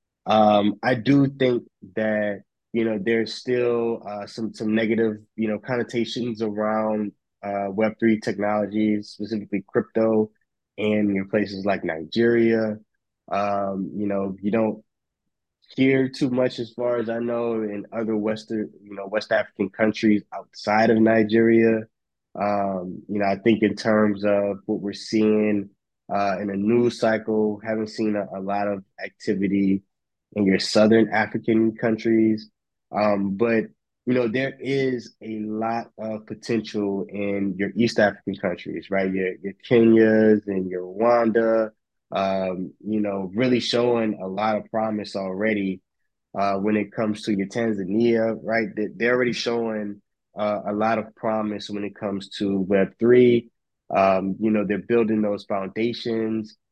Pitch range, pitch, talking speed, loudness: 100-115 Hz, 110 Hz, 150 wpm, -23 LUFS